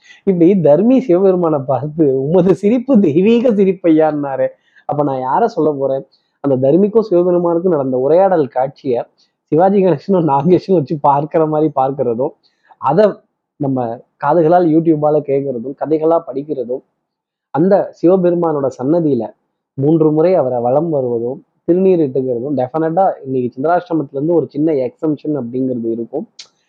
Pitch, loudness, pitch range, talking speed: 155 Hz, -14 LUFS, 135-175 Hz, 115 wpm